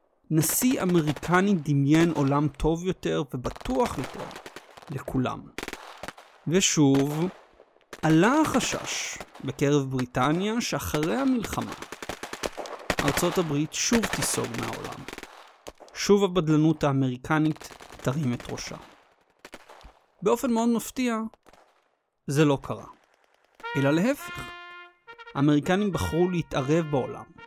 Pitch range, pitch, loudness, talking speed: 145-220 Hz, 160 Hz, -26 LUFS, 85 wpm